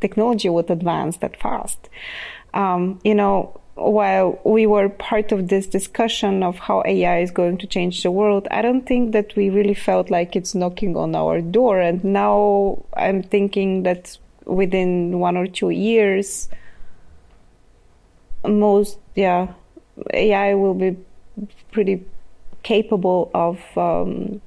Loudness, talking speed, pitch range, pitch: -19 LUFS, 135 wpm, 180-210 Hz, 195 Hz